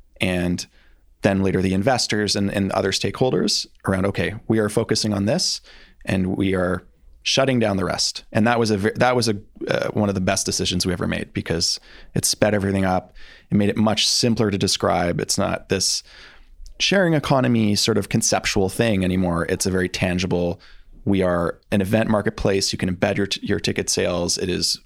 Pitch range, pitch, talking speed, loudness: 95-110 Hz, 100 Hz, 195 wpm, -21 LUFS